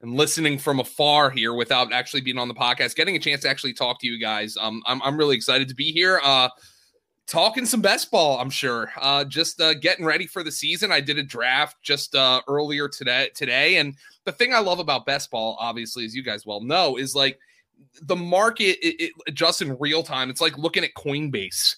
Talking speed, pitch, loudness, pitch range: 225 wpm, 140 Hz, -21 LUFS, 130-165 Hz